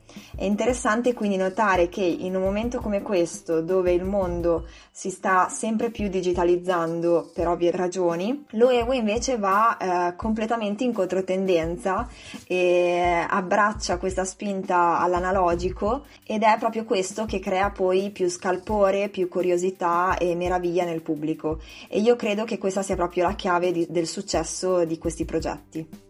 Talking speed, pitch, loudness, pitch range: 145 wpm, 185 Hz, -24 LUFS, 175-210 Hz